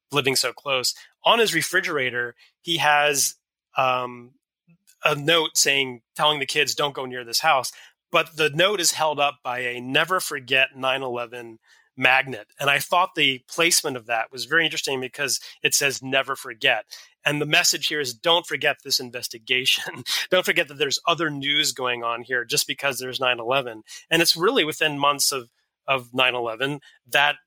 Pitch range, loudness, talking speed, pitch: 125-155 Hz, -21 LUFS, 175 wpm, 140 Hz